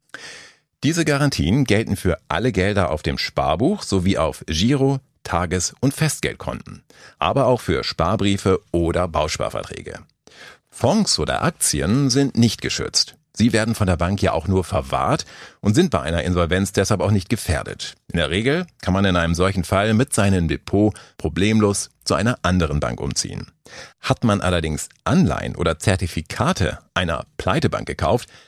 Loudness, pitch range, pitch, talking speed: -20 LUFS, 85-115 Hz, 95 Hz, 150 wpm